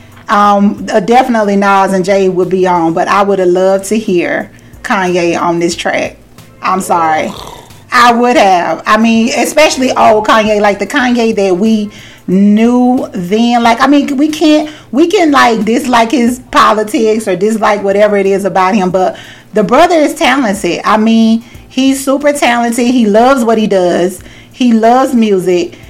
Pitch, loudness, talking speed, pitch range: 220 Hz, -9 LUFS, 170 wpm, 195-250 Hz